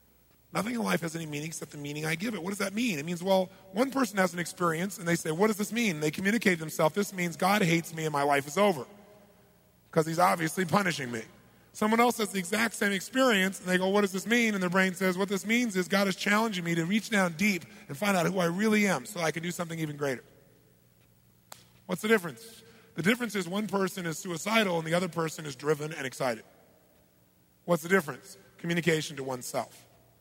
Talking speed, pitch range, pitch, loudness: 235 wpm, 160-205 Hz, 185 Hz, -29 LUFS